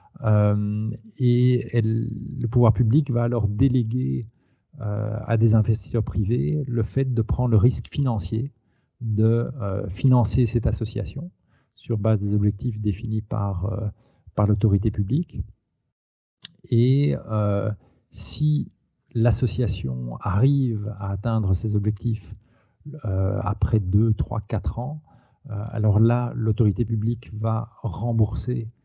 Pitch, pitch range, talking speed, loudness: 115 Hz, 105-120 Hz, 120 wpm, -23 LUFS